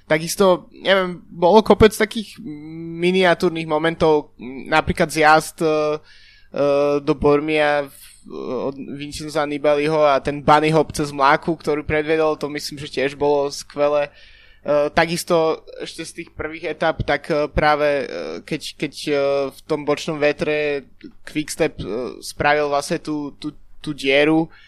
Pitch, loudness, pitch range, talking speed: 150 Hz, -19 LUFS, 145-165 Hz, 140 wpm